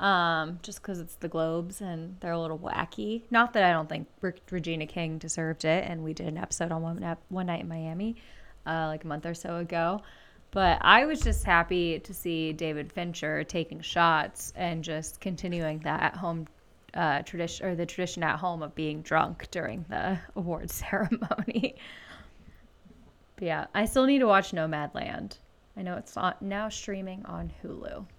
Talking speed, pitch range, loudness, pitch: 185 wpm, 160-185 Hz, -30 LUFS, 170 Hz